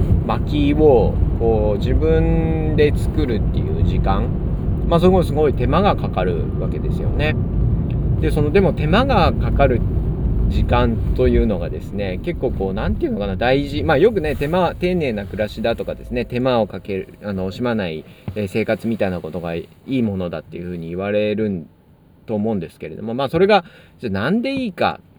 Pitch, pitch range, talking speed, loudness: 105 Hz, 90-120 Hz, 355 characters per minute, -19 LUFS